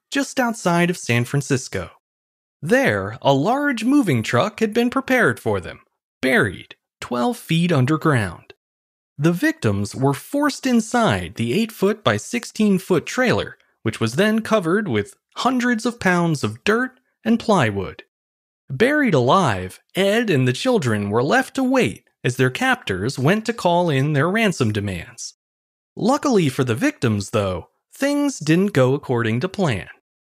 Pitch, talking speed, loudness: 160 Hz, 145 wpm, -20 LUFS